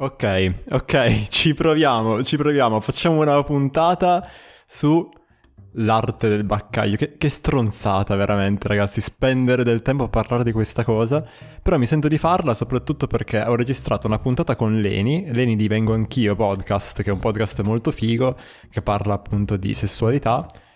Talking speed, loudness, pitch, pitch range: 160 wpm, -20 LUFS, 115 Hz, 105-135 Hz